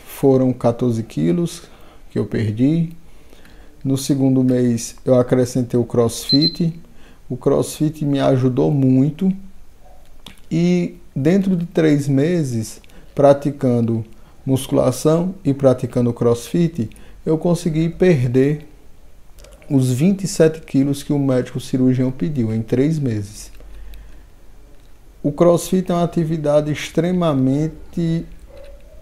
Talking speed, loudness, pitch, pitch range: 100 wpm, -18 LUFS, 135 Hz, 125-165 Hz